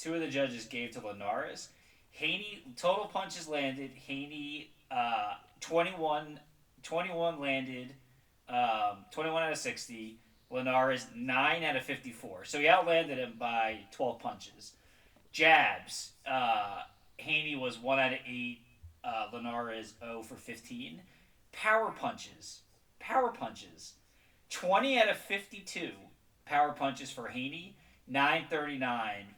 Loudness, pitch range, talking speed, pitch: -33 LUFS, 125-165 Hz, 125 wpm, 140 Hz